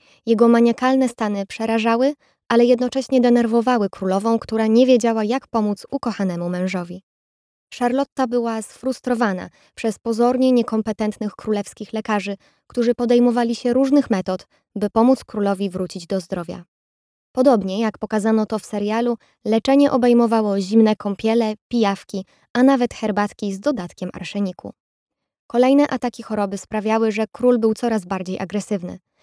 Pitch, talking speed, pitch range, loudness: 225 Hz, 125 wpm, 205-245 Hz, -20 LUFS